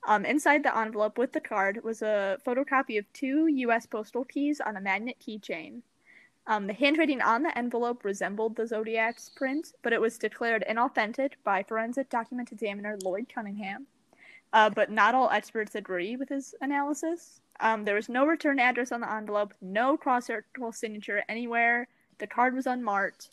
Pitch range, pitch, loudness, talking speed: 215-265 Hz, 230 Hz, -29 LUFS, 170 wpm